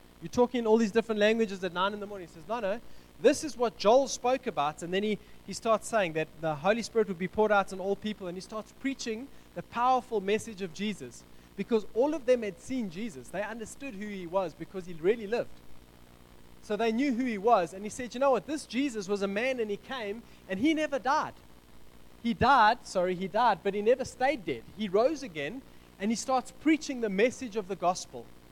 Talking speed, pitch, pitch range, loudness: 230 wpm, 215 Hz, 190-245 Hz, -30 LUFS